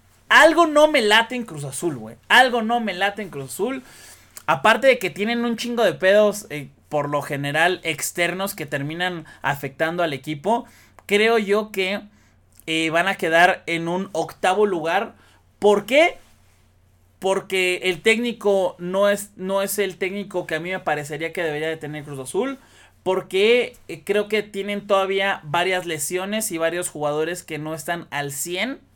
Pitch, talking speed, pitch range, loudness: 180 Hz, 170 wpm, 155-205 Hz, -21 LUFS